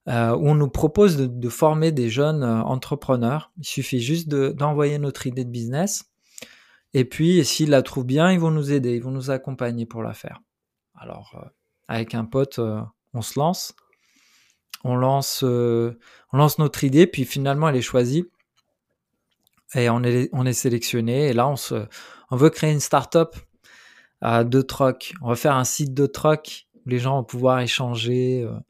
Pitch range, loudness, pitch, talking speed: 120-150 Hz, -21 LUFS, 135 Hz, 190 wpm